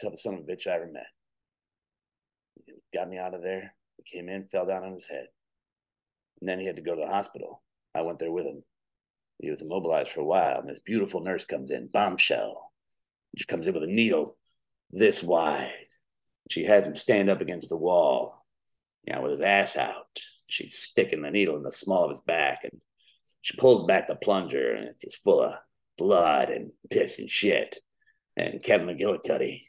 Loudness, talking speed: -27 LUFS, 200 wpm